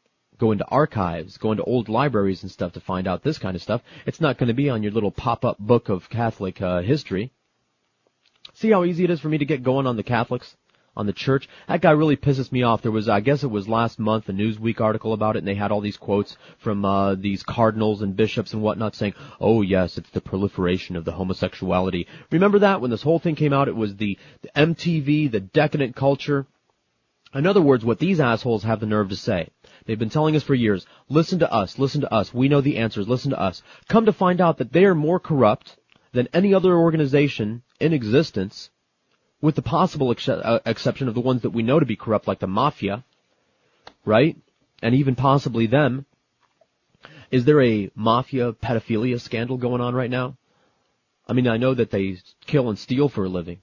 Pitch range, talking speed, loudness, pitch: 105-145 Hz, 215 wpm, -22 LUFS, 120 Hz